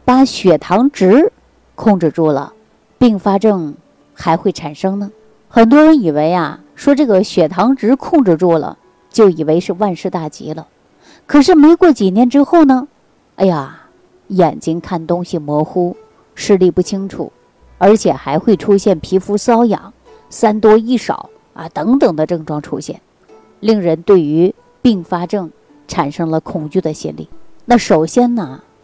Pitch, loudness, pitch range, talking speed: 195 Hz, -13 LUFS, 165-235 Hz, 220 characters per minute